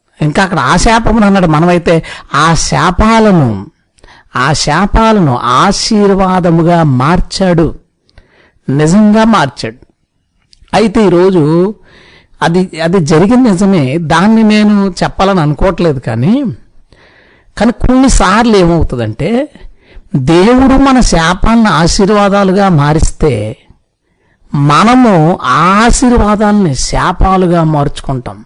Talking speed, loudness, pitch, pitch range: 80 wpm, -8 LUFS, 180 Hz, 150-210 Hz